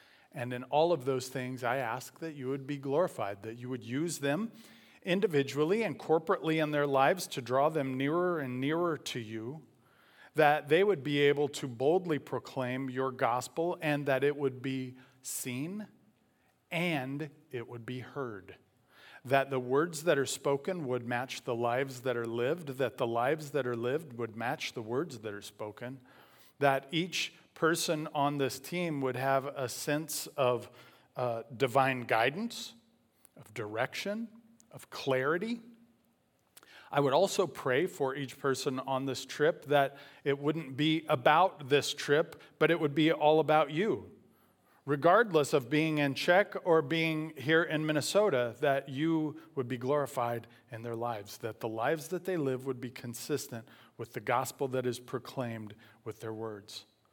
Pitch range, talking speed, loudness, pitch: 125-155 Hz, 165 wpm, -32 LUFS, 135 Hz